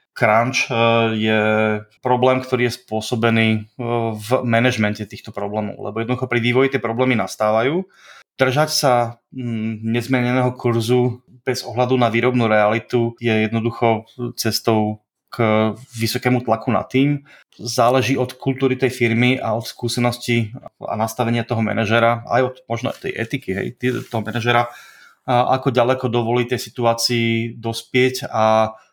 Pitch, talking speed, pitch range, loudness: 120 Hz, 130 wpm, 110-125 Hz, -19 LUFS